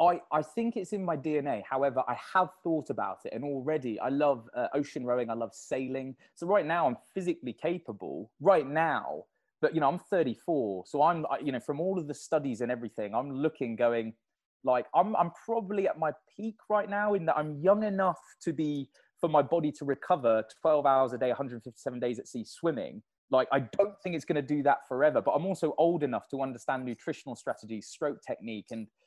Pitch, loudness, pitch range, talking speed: 150 Hz, -31 LUFS, 130-175 Hz, 215 wpm